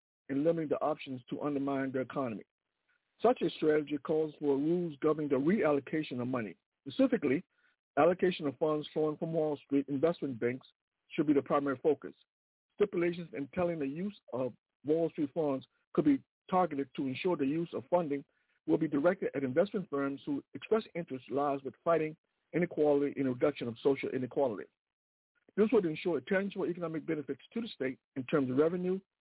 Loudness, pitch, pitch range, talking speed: -33 LUFS, 155 Hz, 140-175 Hz, 175 wpm